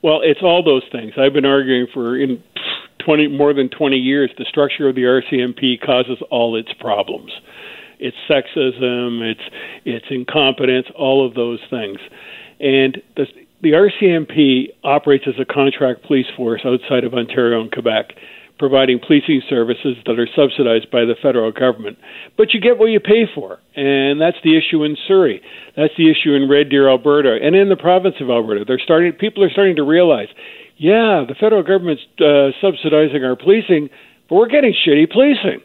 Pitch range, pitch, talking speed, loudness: 130-175 Hz, 140 Hz, 175 wpm, -15 LUFS